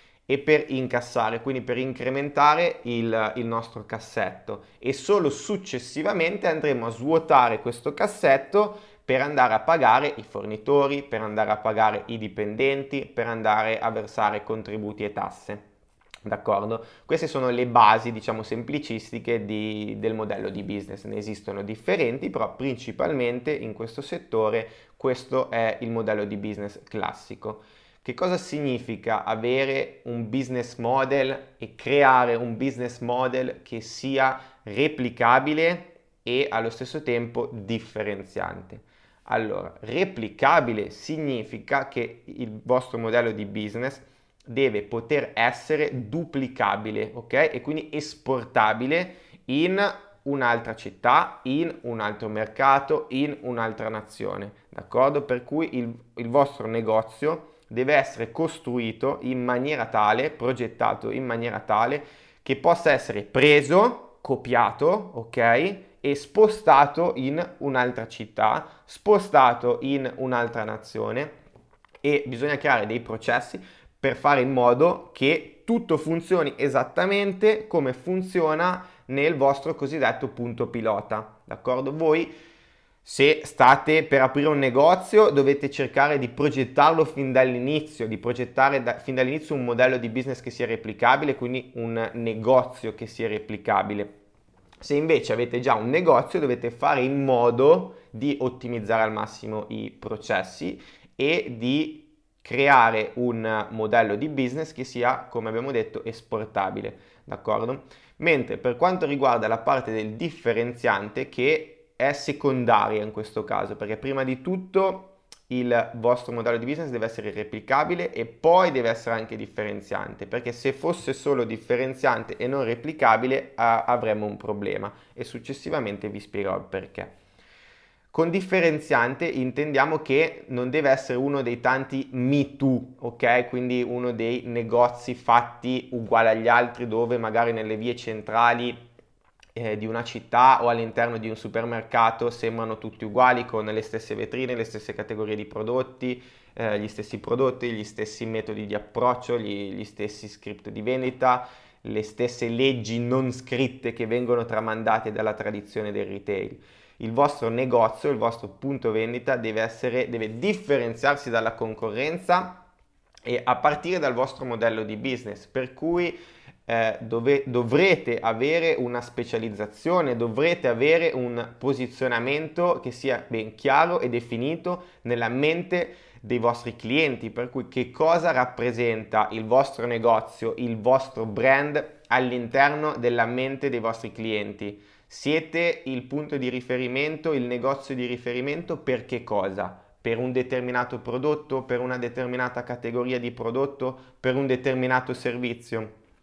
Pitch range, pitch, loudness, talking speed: 115-140 Hz, 125 Hz, -25 LUFS, 135 wpm